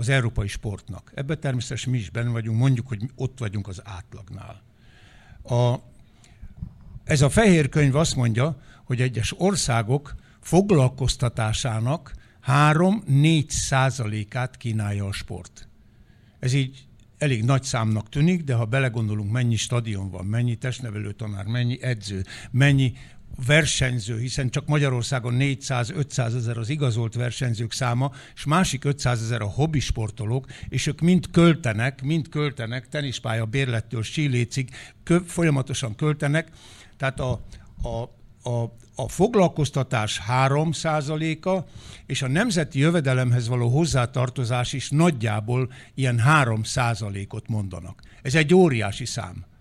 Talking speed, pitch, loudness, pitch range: 120 wpm, 125 Hz, -23 LUFS, 115-140 Hz